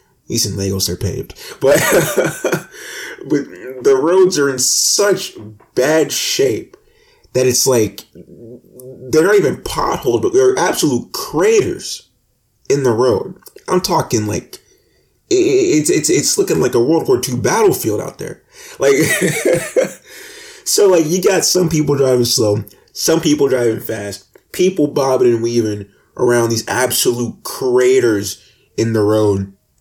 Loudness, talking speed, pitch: -15 LUFS, 135 wpm, 155 Hz